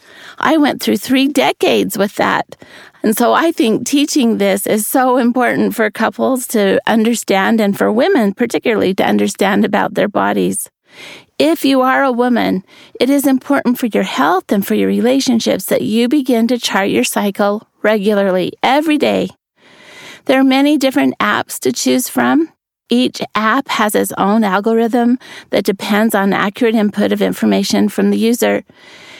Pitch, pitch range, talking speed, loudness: 230 Hz, 205-265 Hz, 160 wpm, -14 LUFS